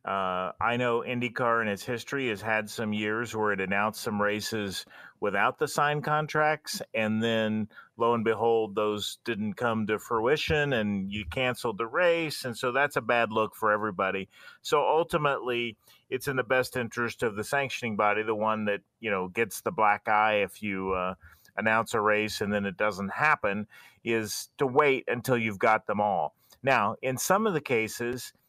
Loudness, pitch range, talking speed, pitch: -28 LUFS, 105-125 Hz, 185 wpm, 110 Hz